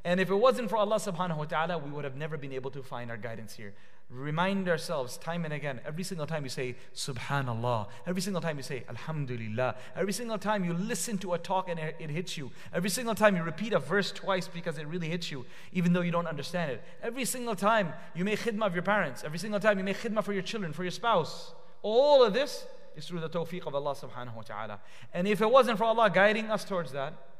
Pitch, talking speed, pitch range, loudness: 170 Hz, 245 wpm, 140-205 Hz, -31 LUFS